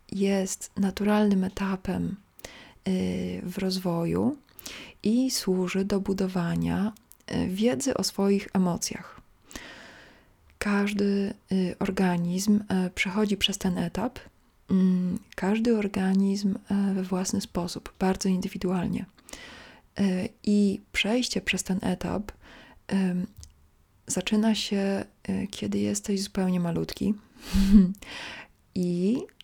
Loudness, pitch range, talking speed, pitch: -27 LUFS, 185-210 Hz, 75 wpm, 195 Hz